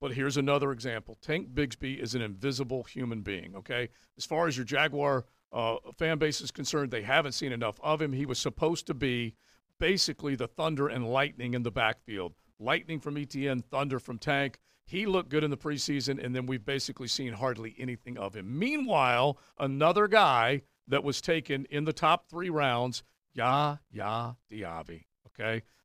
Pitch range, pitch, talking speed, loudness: 120-150 Hz, 135 Hz, 175 wpm, -31 LUFS